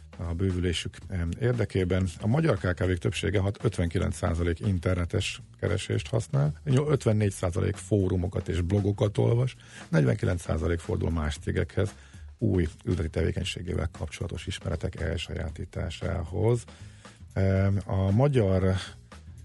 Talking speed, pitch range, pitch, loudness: 90 wpm, 90-110 Hz, 95 Hz, -28 LUFS